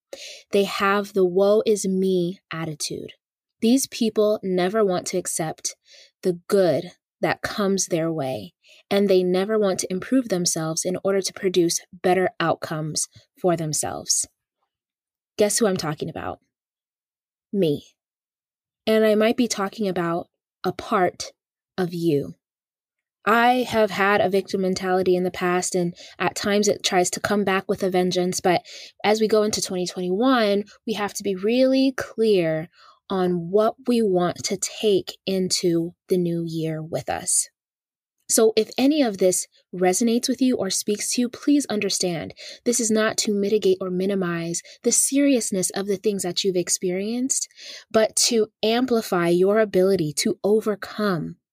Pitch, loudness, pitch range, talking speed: 195 Hz, -22 LUFS, 180-220 Hz, 150 wpm